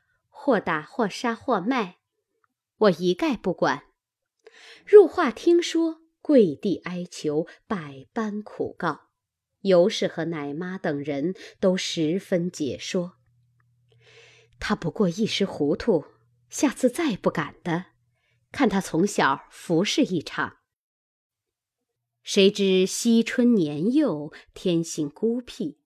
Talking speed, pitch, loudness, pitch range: 155 characters per minute, 185 Hz, -24 LUFS, 155-240 Hz